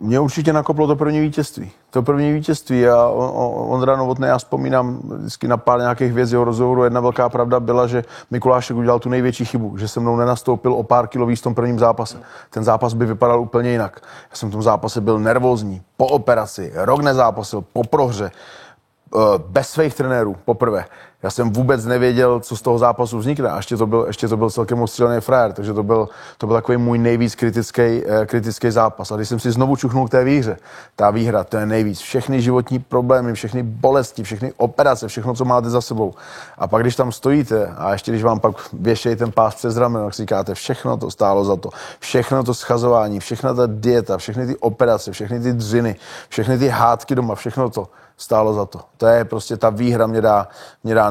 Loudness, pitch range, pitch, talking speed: -18 LUFS, 115-125 Hz, 120 Hz, 205 wpm